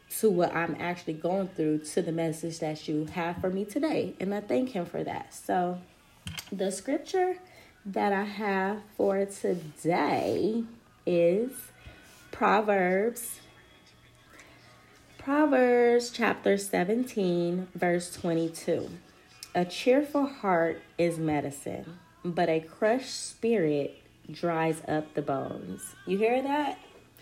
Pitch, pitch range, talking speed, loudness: 185 Hz, 165-225 Hz, 115 wpm, -29 LUFS